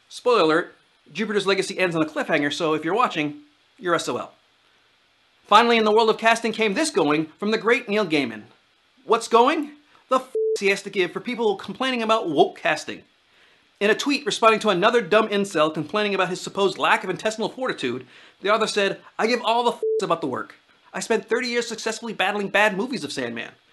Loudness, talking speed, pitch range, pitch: -22 LUFS, 200 wpm, 195-235 Hz, 215 Hz